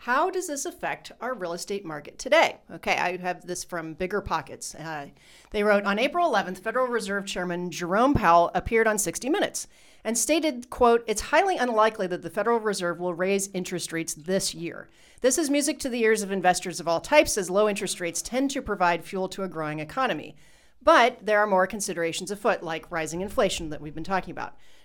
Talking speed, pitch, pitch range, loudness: 205 wpm, 195 Hz, 175-235 Hz, -25 LUFS